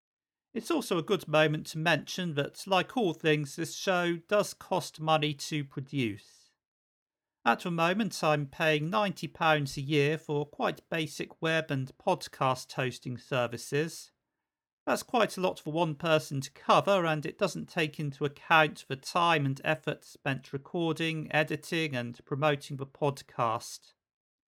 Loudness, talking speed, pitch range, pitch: -30 LUFS, 145 wpm, 145-170 Hz, 155 Hz